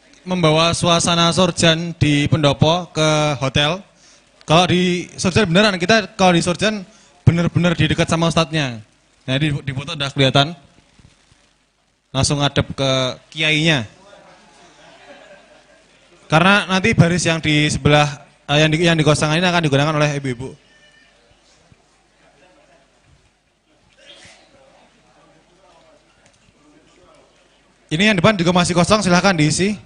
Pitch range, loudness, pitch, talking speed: 145-175 Hz, -16 LUFS, 160 Hz, 105 wpm